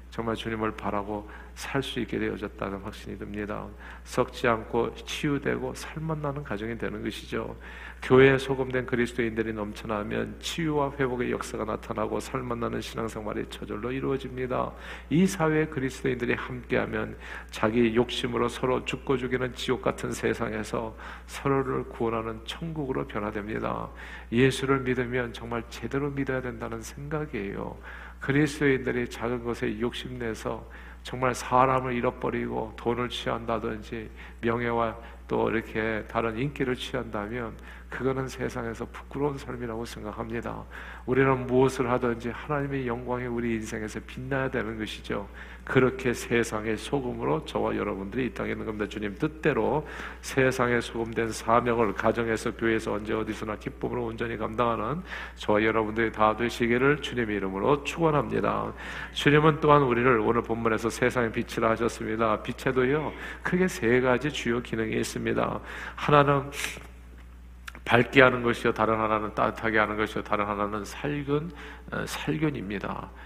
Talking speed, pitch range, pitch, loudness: 350 characters per minute, 110-130 Hz, 115 Hz, -28 LUFS